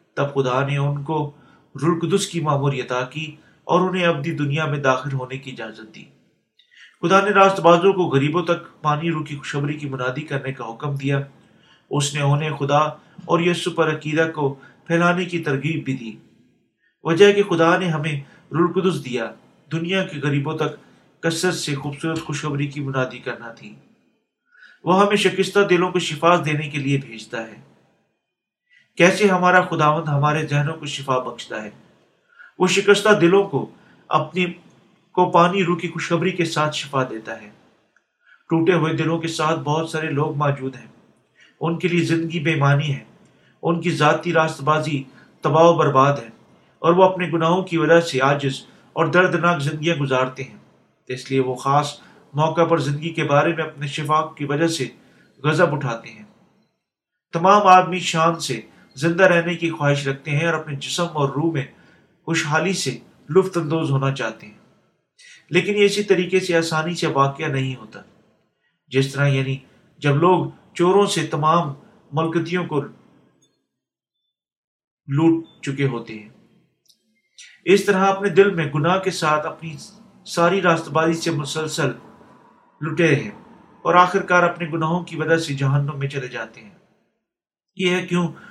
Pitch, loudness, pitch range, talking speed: 160 Hz, -20 LUFS, 145-175 Hz, 160 wpm